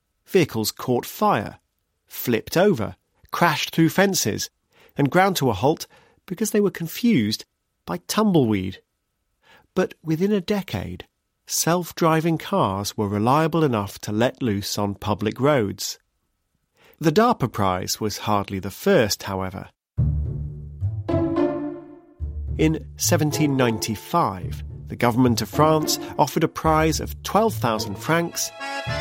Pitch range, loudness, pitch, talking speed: 100-165 Hz, -22 LUFS, 125 Hz, 115 wpm